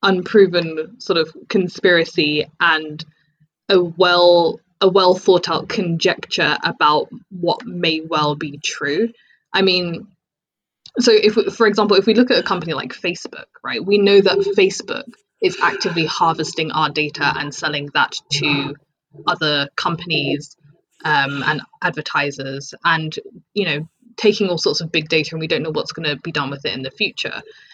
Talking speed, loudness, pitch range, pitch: 160 wpm, -18 LUFS, 150-200 Hz, 170 Hz